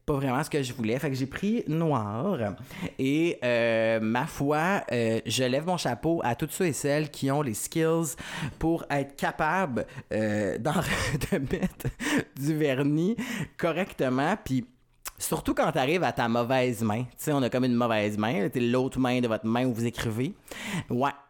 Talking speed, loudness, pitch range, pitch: 185 wpm, -28 LUFS, 120-155 Hz, 130 Hz